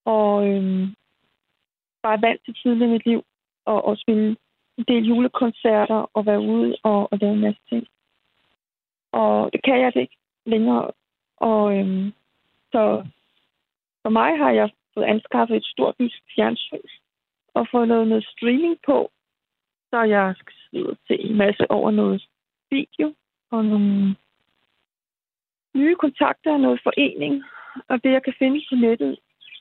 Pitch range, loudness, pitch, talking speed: 205-250 Hz, -21 LUFS, 225 Hz, 150 wpm